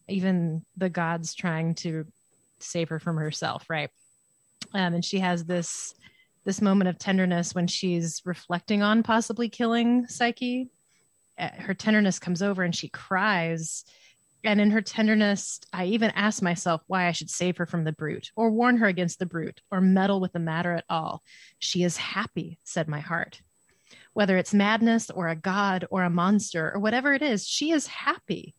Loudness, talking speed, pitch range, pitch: -26 LUFS, 175 wpm, 170-210 Hz, 185 Hz